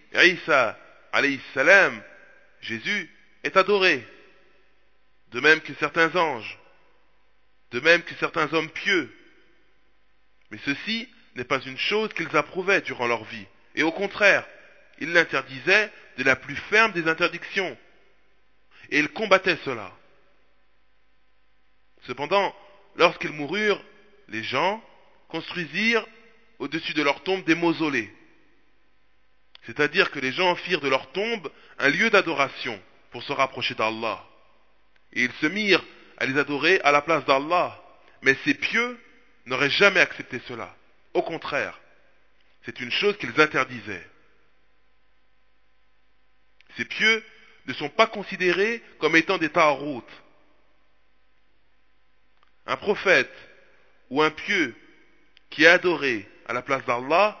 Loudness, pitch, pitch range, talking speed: -23 LUFS, 150 Hz, 120-190 Hz, 120 wpm